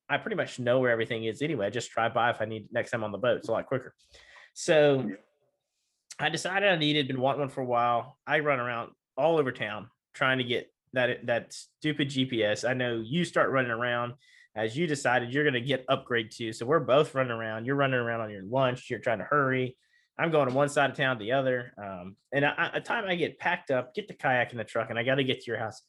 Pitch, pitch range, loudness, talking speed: 130 Hz, 120-150 Hz, -28 LUFS, 255 wpm